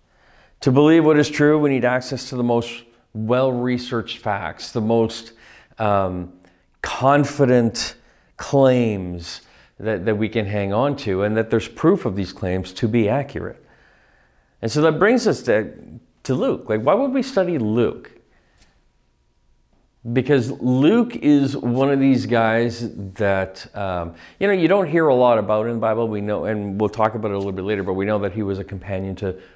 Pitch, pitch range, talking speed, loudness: 115 Hz, 100-130 Hz, 180 wpm, -20 LUFS